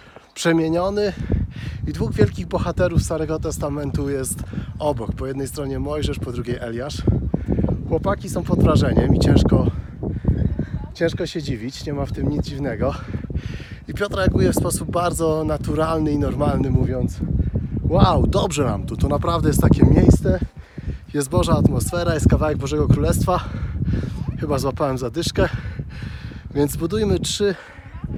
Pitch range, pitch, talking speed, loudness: 125-160 Hz, 145 Hz, 135 wpm, -21 LUFS